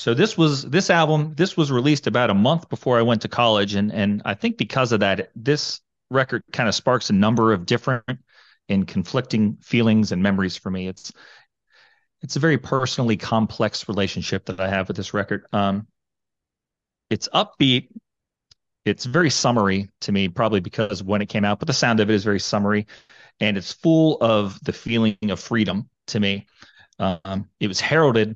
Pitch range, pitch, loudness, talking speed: 100-130 Hz, 110 Hz, -21 LUFS, 185 wpm